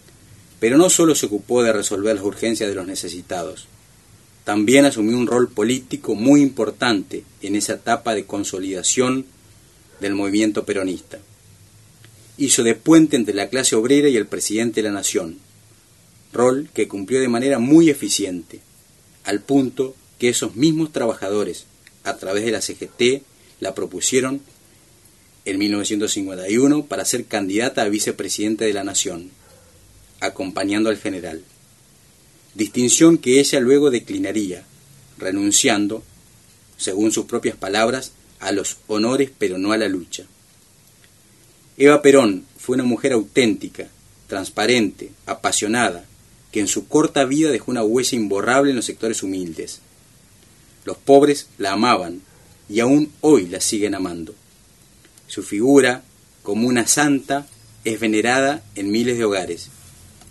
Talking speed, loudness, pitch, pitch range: 130 wpm, -19 LUFS, 115 Hz, 105-140 Hz